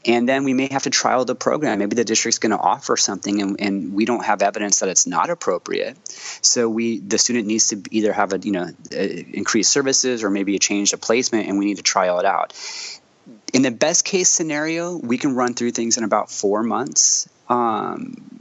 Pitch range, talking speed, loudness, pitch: 100-135 Hz, 220 wpm, -19 LUFS, 115 Hz